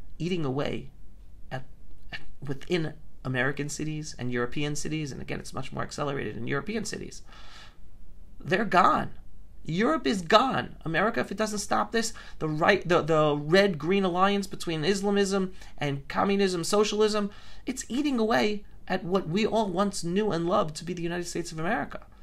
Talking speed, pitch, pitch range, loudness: 160 wpm, 185 Hz, 155-205 Hz, -27 LUFS